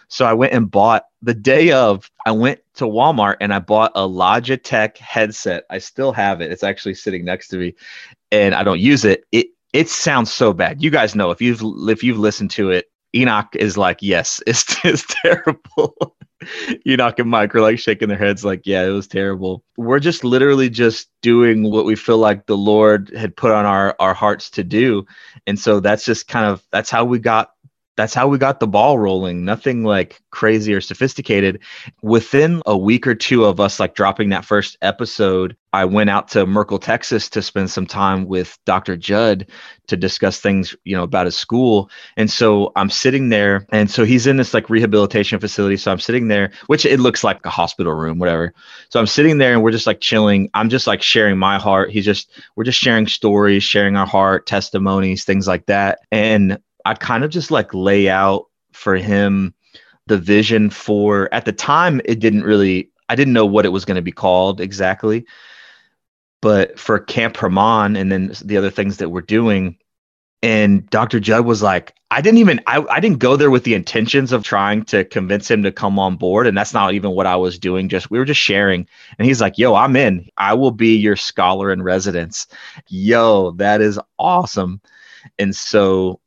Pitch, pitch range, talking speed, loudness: 105 Hz, 95-115 Hz, 205 wpm, -15 LUFS